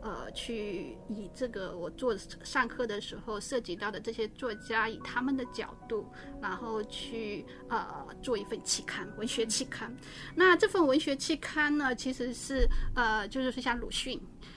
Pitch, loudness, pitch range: 240 Hz, -33 LUFS, 215-260 Hz